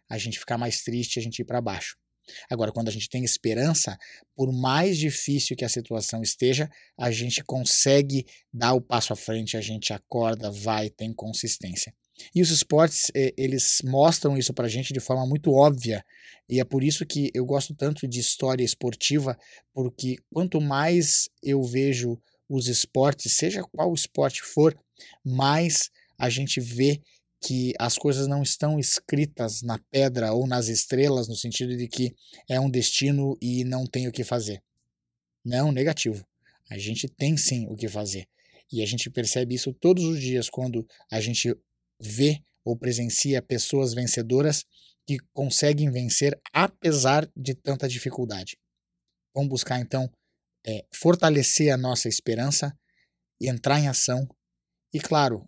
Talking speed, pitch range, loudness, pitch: 155 wpm, 115-140 Hz, -24 LUFS, 125 Hz